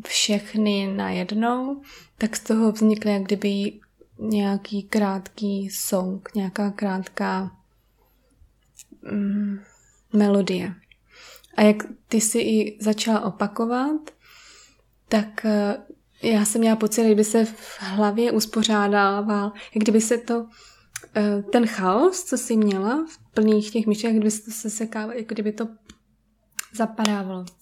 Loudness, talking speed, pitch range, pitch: -23 LUFS, 120 wpm, 205-225 Hz, 215 Hz